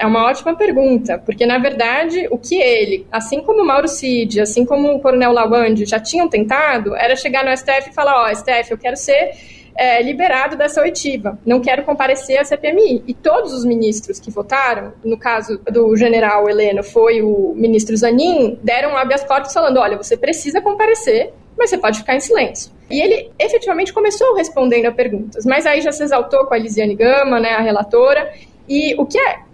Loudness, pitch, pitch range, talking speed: -15 LUFS, 260 Hz, 230-295 Hz, 200 wpm